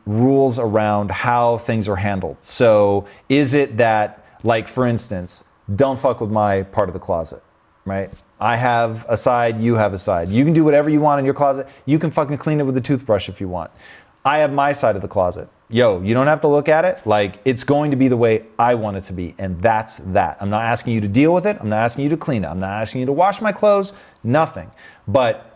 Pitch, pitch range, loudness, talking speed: 115 Hz, 105-140 Hz, -18 LUFS, 245 wpm